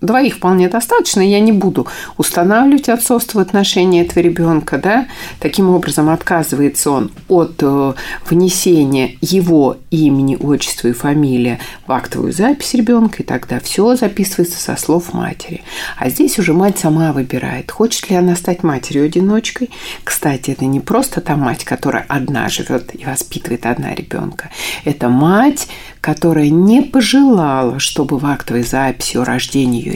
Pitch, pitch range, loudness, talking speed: 170 Hz, 140-205 Hz, -14 LUFS, 145 wpm